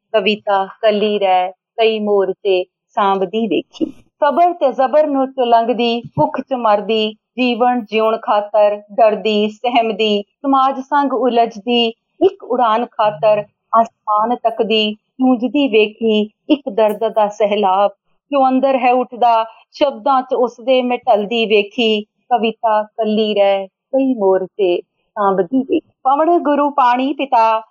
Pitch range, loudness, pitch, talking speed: 210-260 Hz, -16 LUFS, 225 Hz, 125 wpm